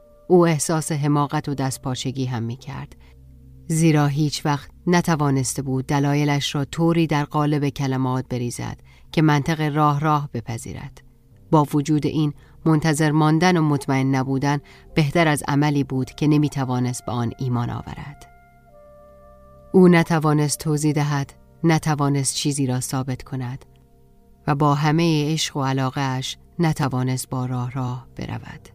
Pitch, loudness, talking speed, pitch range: 140 Hz, -21 LUFS, 135 wpm, 125-150 Hz